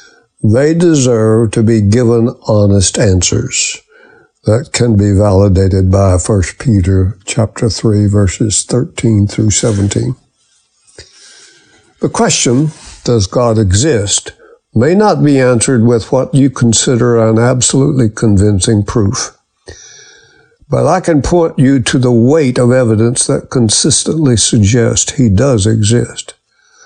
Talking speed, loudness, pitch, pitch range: 120 wpm, -10 LUFS, 120 Hz, 110-145 Hz